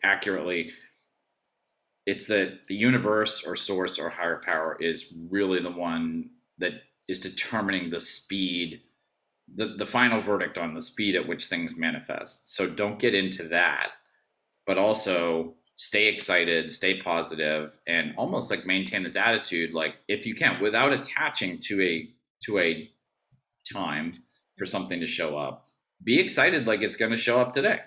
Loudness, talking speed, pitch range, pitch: -26 LUFS, 155 wpm, 80-105 Hz, 90 Hz